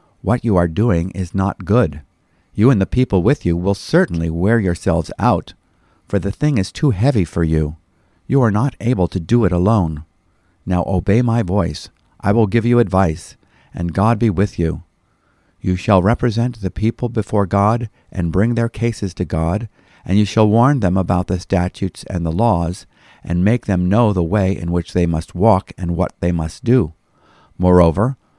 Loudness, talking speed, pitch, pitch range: -17 LUFS, 190 wpm, 95 Hz, 85-115 Hz